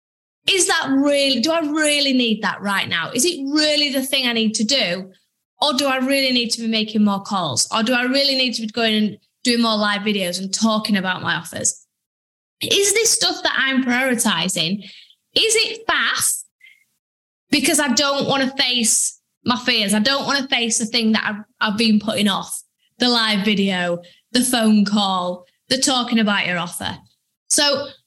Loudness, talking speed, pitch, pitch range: -18 LUFS, 190 wpm, 235 Hz, 210-275 Hz